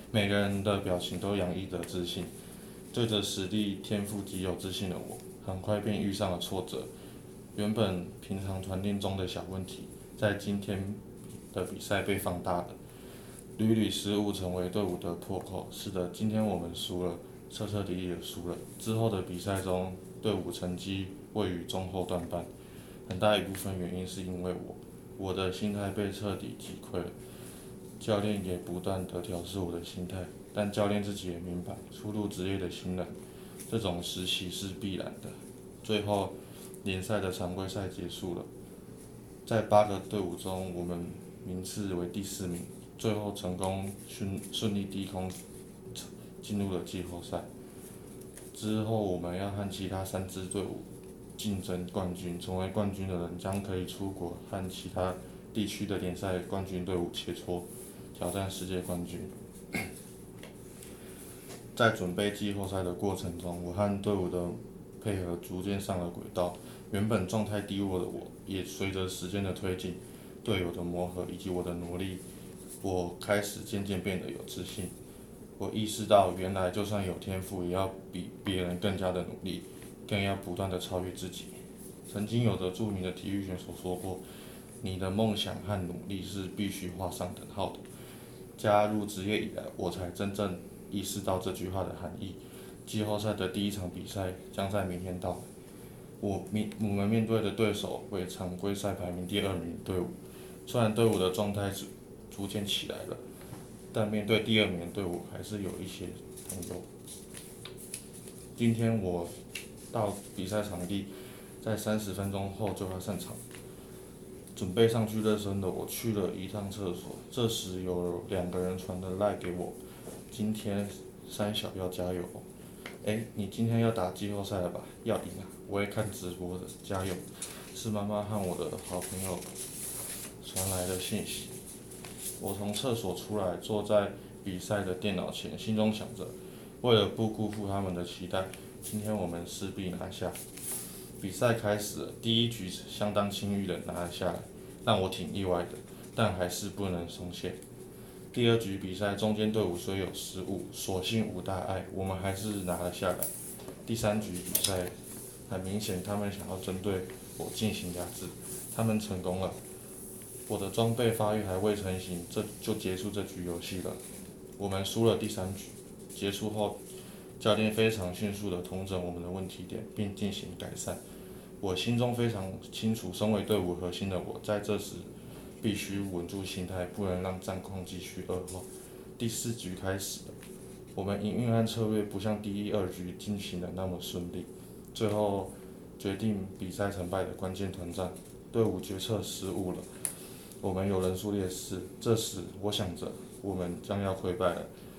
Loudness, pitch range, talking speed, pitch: -34 LUFS, 90-105 Hz, 245 characters per minute, 95 Hz